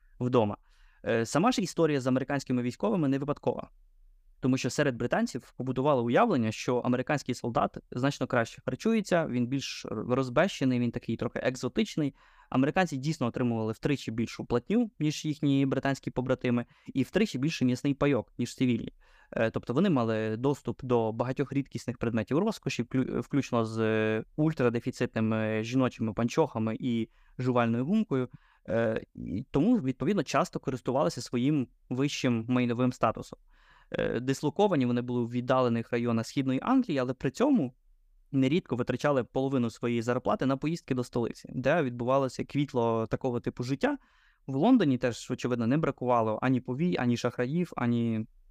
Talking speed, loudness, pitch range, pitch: 135 wpm, -29 LUFS, 120-145 Hz, 130 Hz